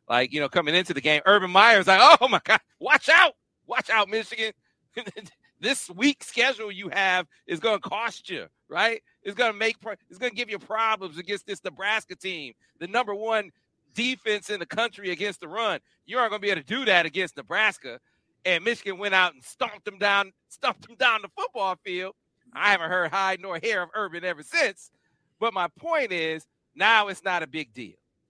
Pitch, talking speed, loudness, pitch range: 200 Hz, 200 wpm, -23 LUFS, 180-220 Hz